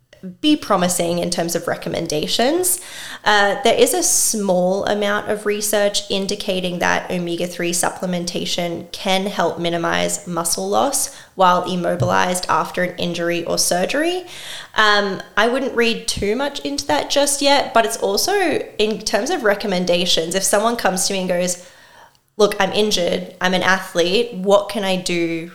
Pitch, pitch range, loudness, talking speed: 195 Hz, 175-215 Hz, -18 LUFS, 155 wpm